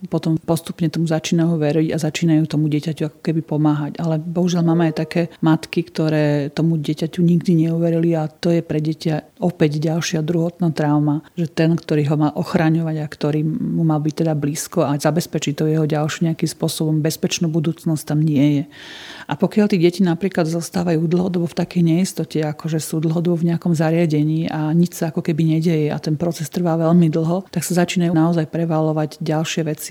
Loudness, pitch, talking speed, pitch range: -19 LUFS, 160 Hz, 185 wpm, 155-170 Hz